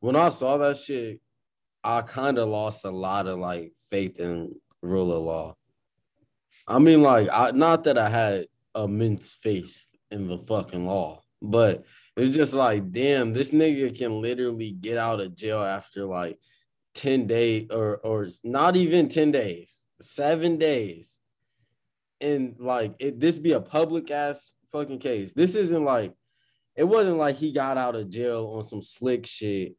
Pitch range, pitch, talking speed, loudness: 100-140 Hz, 115 Hz, 165 wpm, -25 LUFS